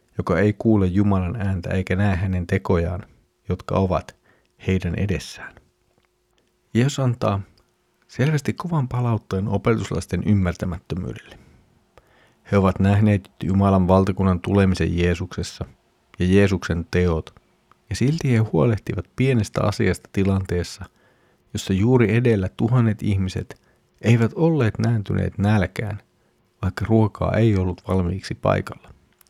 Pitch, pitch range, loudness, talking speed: 100 Hz, 95-110 Hz, -21 LUFS, 105 wpm